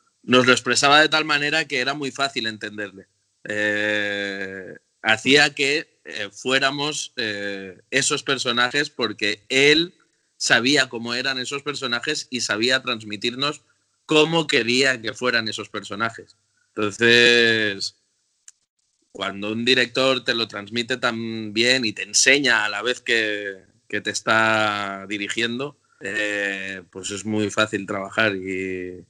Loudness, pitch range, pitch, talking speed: -20 LUFS, 105-135 Hz, 115 Hz, 125 wpm